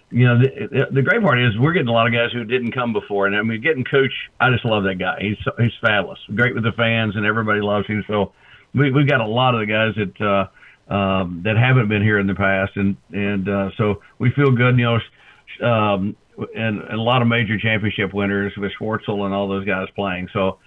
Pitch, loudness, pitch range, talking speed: 110 Hz, -19 LUFS, 100-120 Hz, 240 wpm